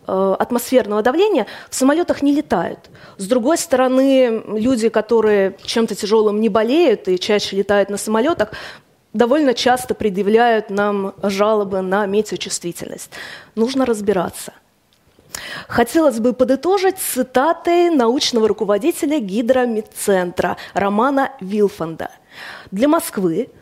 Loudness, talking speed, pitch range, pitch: -17 LUFS, 100 wpm, 205-260 Hz, 225 Hz